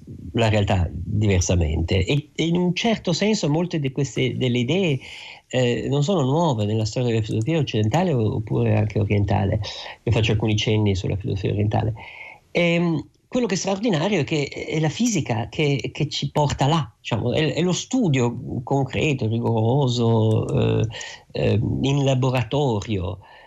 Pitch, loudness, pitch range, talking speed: 125 Hz, -22 LUFS, 110-155 Hz, 150 wpm